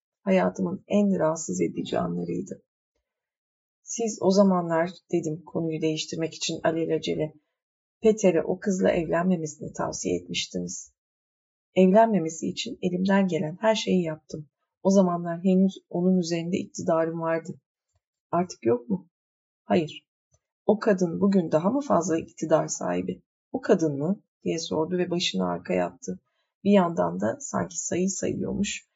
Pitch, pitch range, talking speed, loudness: 170 Hz, 155-190 Hz, 125 wpm, -26 LUFS